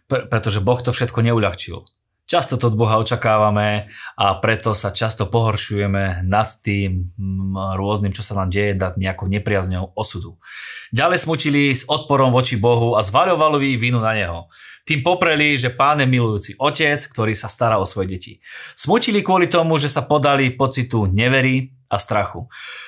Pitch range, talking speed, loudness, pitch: 100-135 Hz, 155 wpm, -18 LUFS, 110 Hz